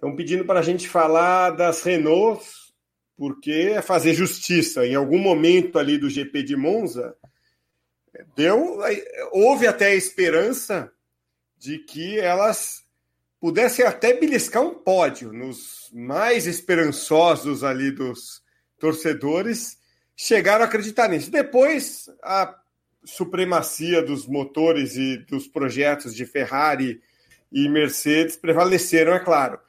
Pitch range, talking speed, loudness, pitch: 140-190 Hz, 115 wpm, -20 LUFS, 165 Hz